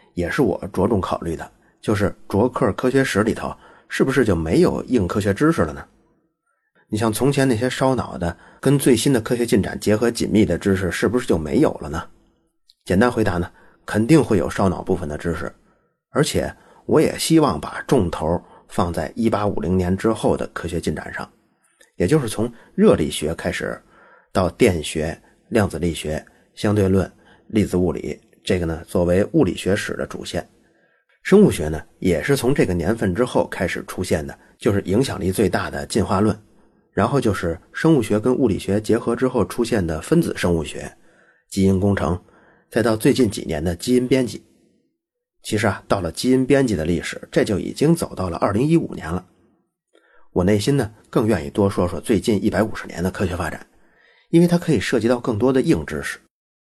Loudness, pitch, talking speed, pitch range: -20 LUFS, 110 Hz, 275 characters per minute, 90-130 Hz